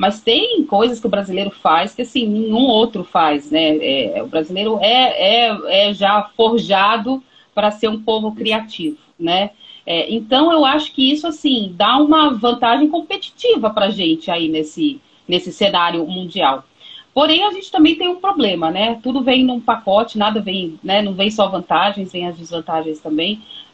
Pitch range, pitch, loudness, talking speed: 185-265 Hz, 220 Hz, -16 LUFS, 175 wpm